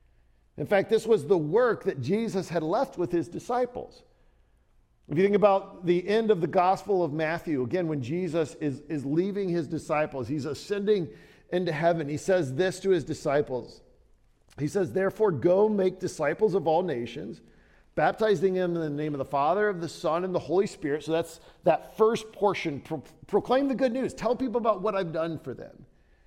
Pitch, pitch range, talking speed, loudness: 170 Hz, 150-200 Hz, 190 wpm, -27 LUFS